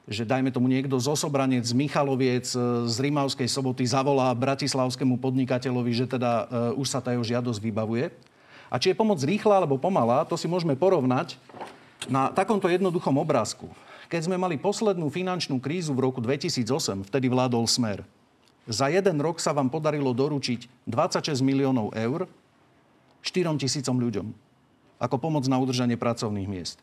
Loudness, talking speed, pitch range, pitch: -26 LUFS, 160 wpm, 125-150 Hz, 135 Hz